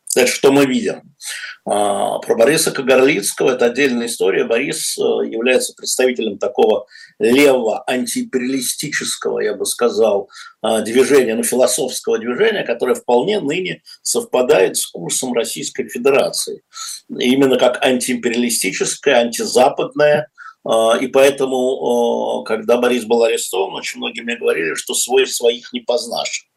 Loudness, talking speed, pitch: -16 LUFS, 110 wpm, 145 Hz